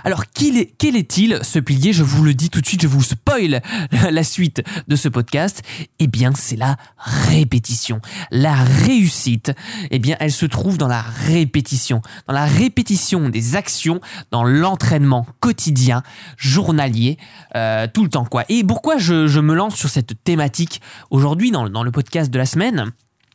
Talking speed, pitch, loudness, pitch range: 175 wpm, 145 Hz, -16 LUFS, 125-170 Hz